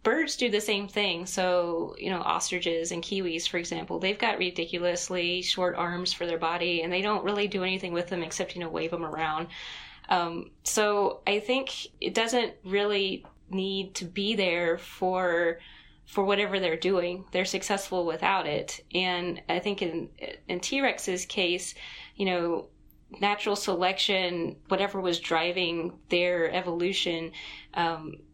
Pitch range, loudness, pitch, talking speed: 170-200 Hz, -28 LUFS, 180 Hz, 155 wpm